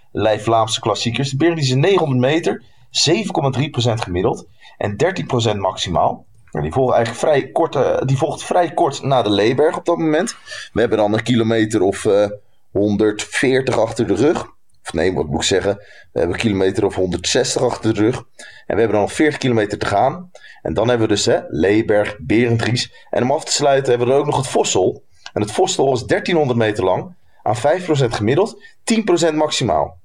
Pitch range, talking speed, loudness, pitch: 105-135 Hz, 190 wpm, -17 LUFS, 120 Hz